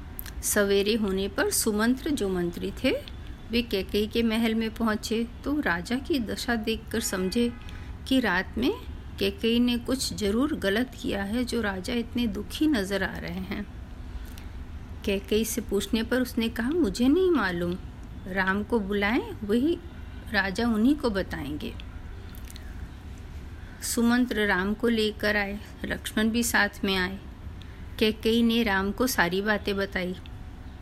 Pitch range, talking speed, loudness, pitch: 175-235 Hz, 140 wpm, -27 LUFS, 210 Hz